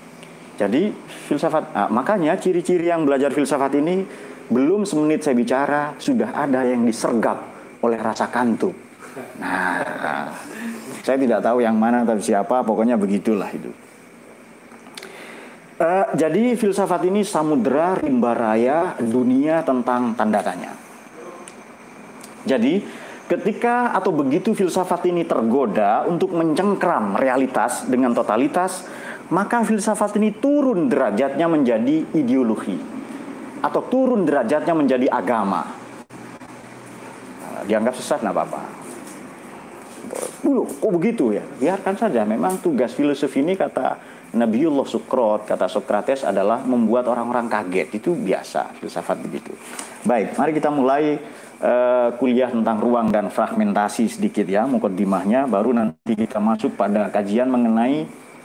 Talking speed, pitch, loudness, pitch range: 115 wpm, 145 Hz, -20 LUFS, 120-195 Hz